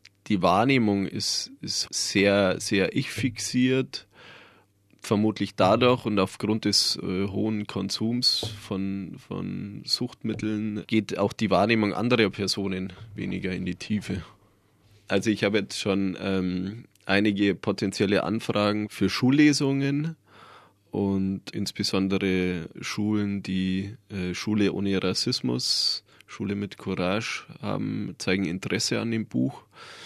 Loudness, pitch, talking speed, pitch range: -26 LUFS, 100 Hz, 110 wpm, 95-110 Hz